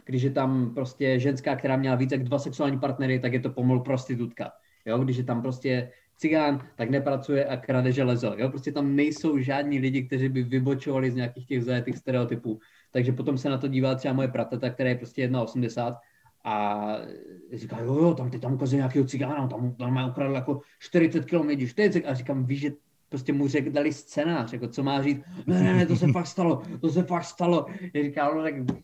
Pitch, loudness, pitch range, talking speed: 135 Hz, -27 LUFS, 125-145 Hz, 215 wpm